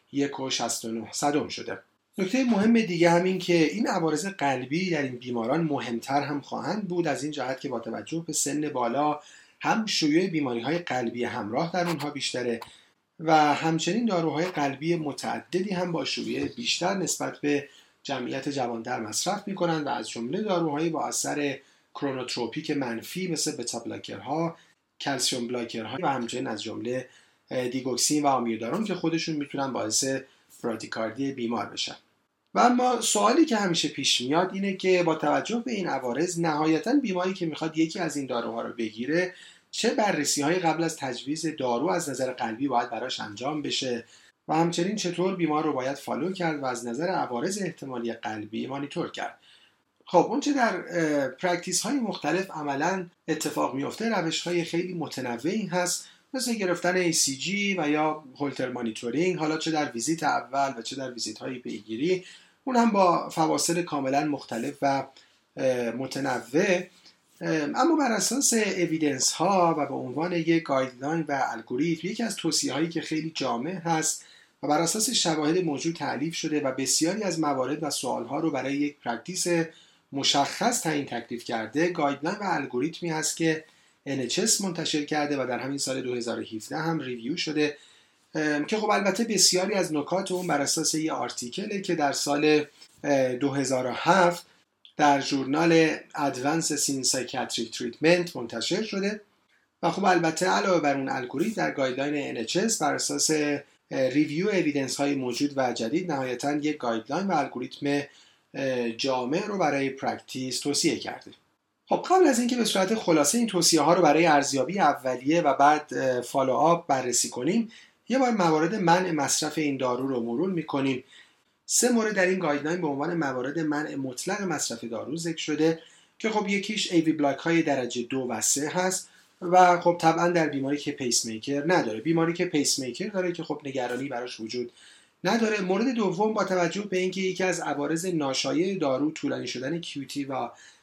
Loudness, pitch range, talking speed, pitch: -26 LUFS, 135-180 Hz, 160 wpm, 155 Hz